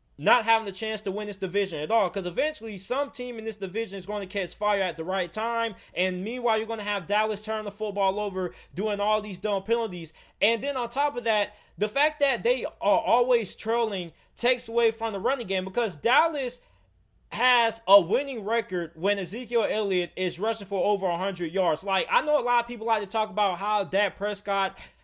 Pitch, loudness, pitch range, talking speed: 210 Hz, -26 LUFS, 195-230 Hz, 215 wpm